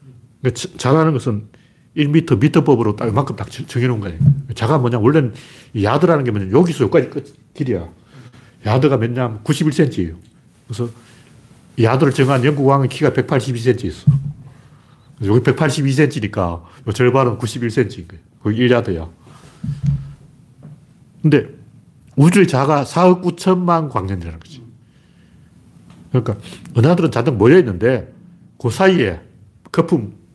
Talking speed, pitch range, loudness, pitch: 265 characters per minute, 120-150 Hz, -16 LUFS, 130 Hz